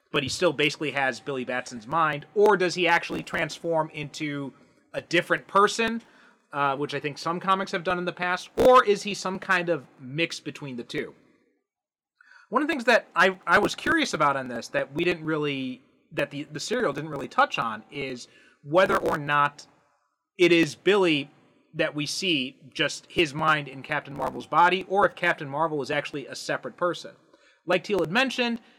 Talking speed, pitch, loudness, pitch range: 190 wpm, 155 Hz, -25 LUFS, 145-180 Hz